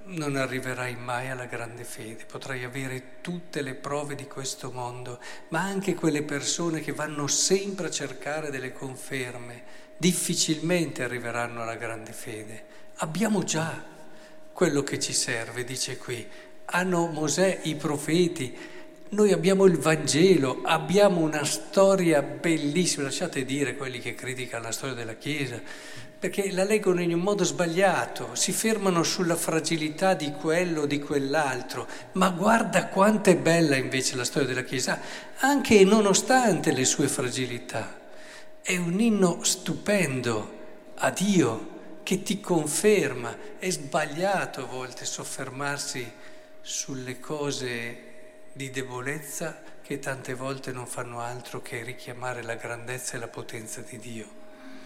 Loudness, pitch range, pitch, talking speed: -26 LUFS, 130-180 Hz, 150 Hz, 135 wpm